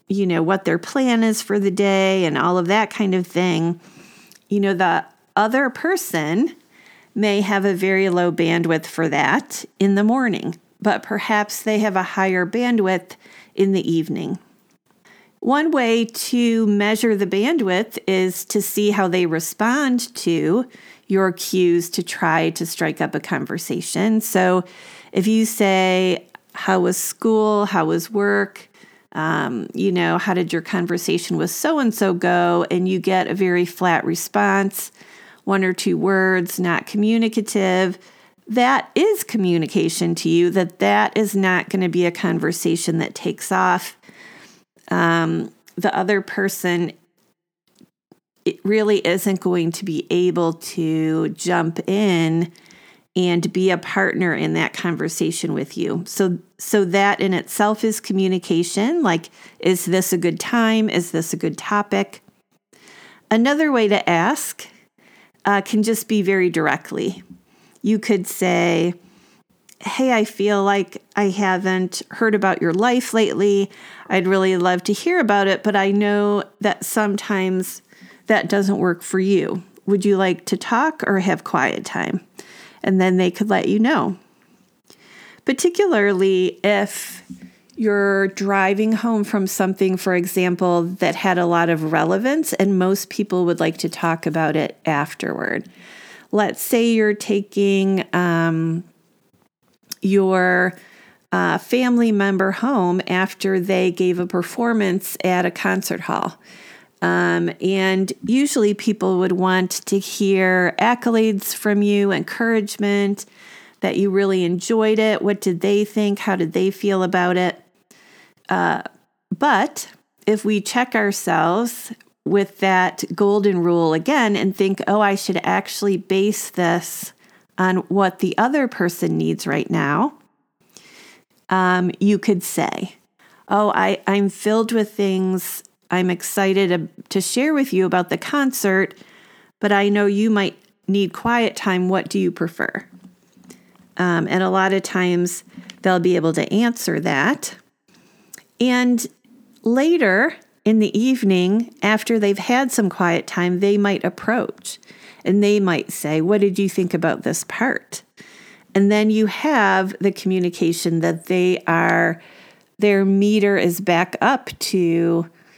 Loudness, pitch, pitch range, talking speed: -19 LUFS, 195 Hz, 180-210 Hz, 145 wpm